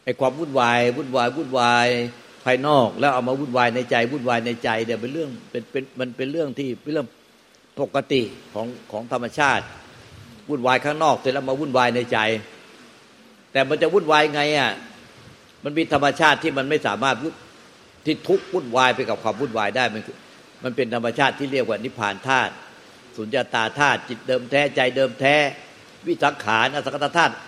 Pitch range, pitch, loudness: 120-145 Hz, 130 Hz, -21 LUFS